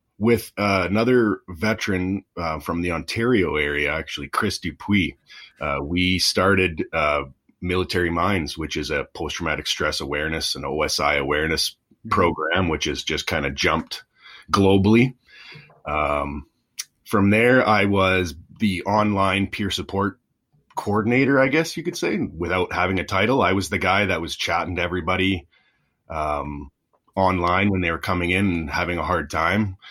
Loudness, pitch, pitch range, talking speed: -22 LUFS, 95 Hz, 90-105 Hz, 150 wpm